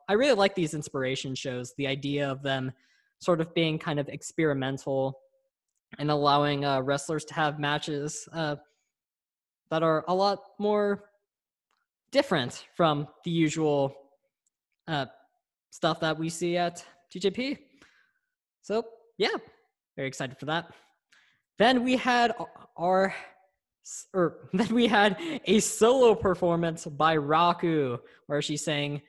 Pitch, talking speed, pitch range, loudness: 165 Hz, 130 wpm, 145-205 Hz, -27 LUFS